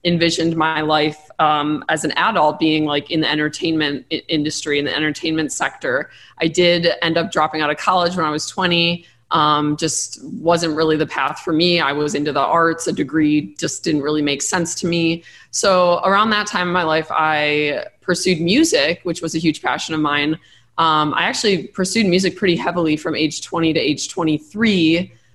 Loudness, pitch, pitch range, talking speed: -18 LUFS, 160 Hz, 150-175 Hz, 190 wpm